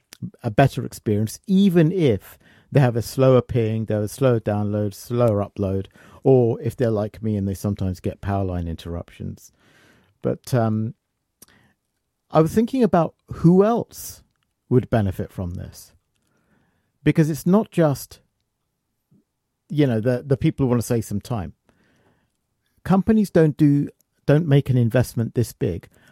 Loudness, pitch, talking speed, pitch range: -21 LUFS, 120 Hz, 150 wpm, 105-145 Hz